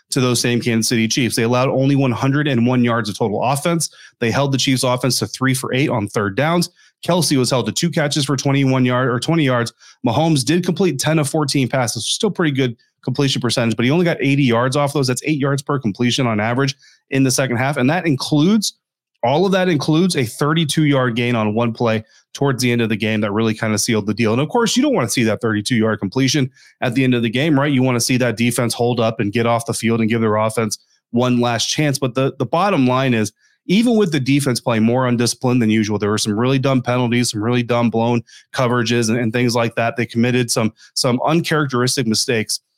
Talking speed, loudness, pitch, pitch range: 240 wpm, -17 LUFS, 125 Hz, 115-140 Hz